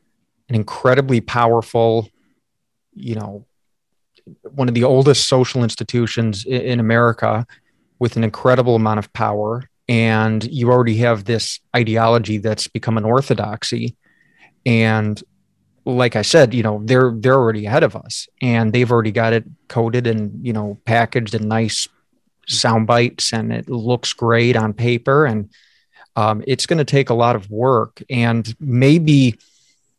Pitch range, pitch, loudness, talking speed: 110-125 Hz, 115 Hz, -17 LUFS, 145 wpm